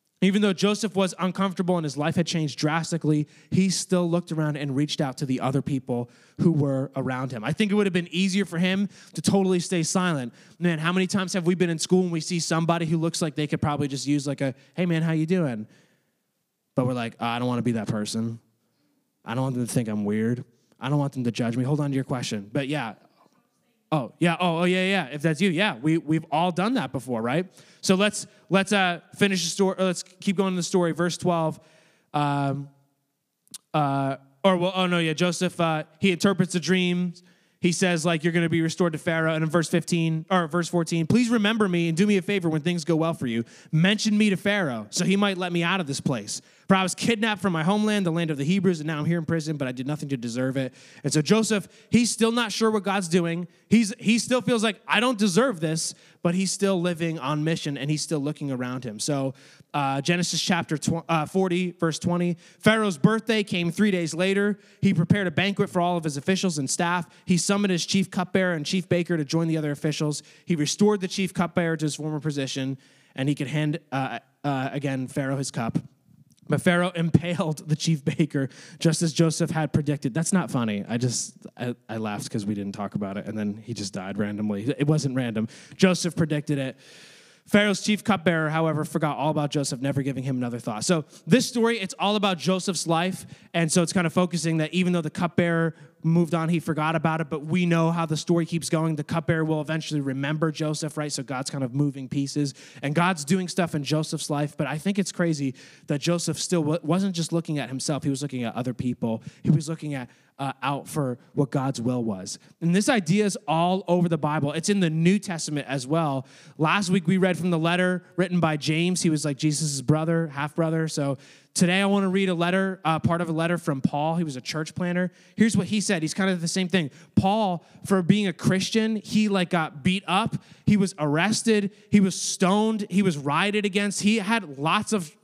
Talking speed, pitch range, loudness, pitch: 230 wpm, 145-185 Hz, -25 LUFS, 165 Hz